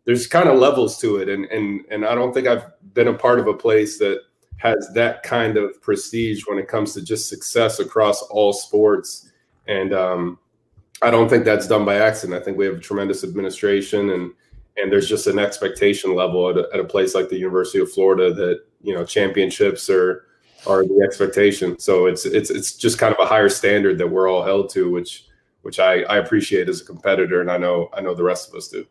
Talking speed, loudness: 225 wpm, -19 LUFS